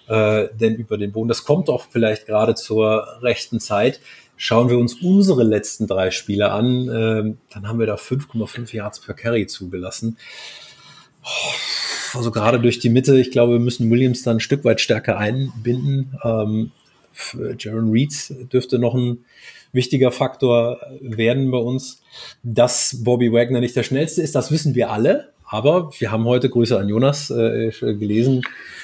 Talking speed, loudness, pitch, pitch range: 155 wpm, -19 LUFS, 120 Hz, 110-130 Hz